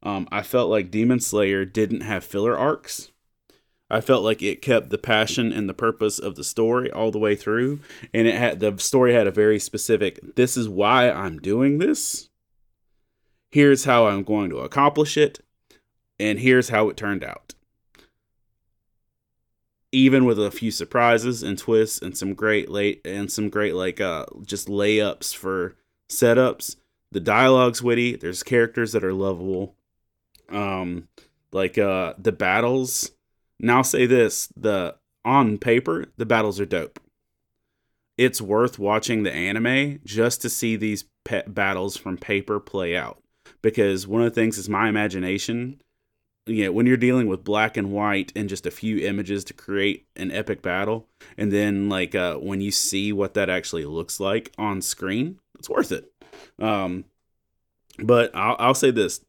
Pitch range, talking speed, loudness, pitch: 100-120 Hz, 165 wpm, -22 LUFS, 110 Hz